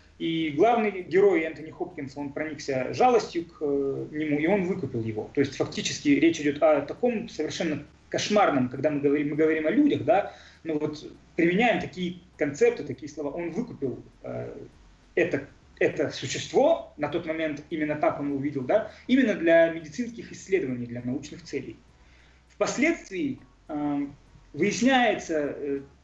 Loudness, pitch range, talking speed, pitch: -26 LUFS, 145-200 Hz, 145 wpm, 155 Hz